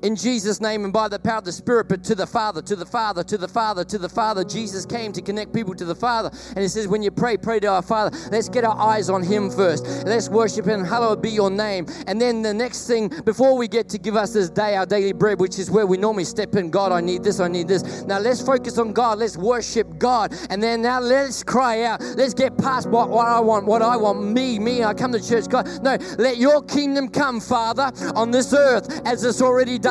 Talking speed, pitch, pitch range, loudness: 260 wpm, 220 Hz, 205-240 Hz, -21 LUFS